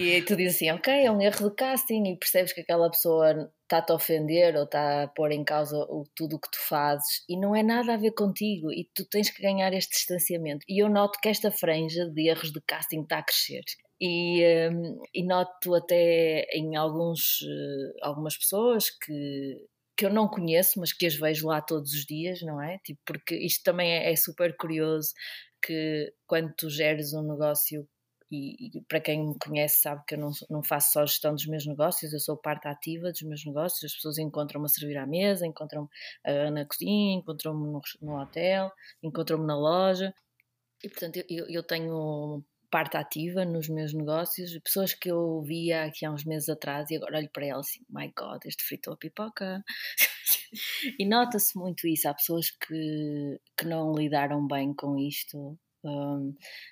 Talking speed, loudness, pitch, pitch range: 195 wpm, -28 LUFS, 160 Hz, 150-180 Hz